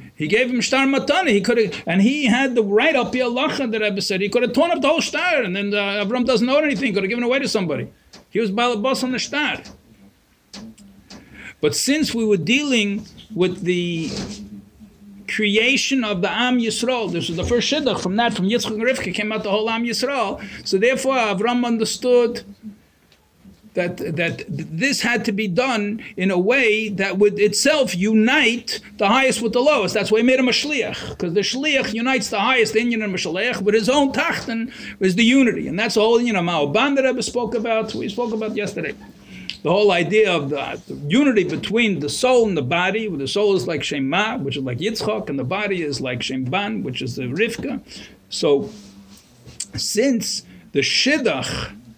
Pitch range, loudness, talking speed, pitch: 195-245 Hz, -19 LUFS, 200 wpm, 220 Hz